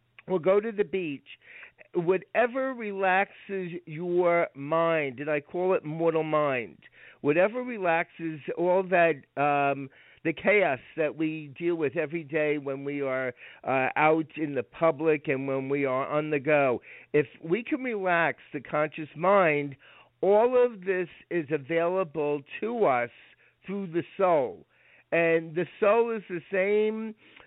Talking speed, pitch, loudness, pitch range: 145 wpm, 165 Hz, -27 LUFS, 150-190 Hz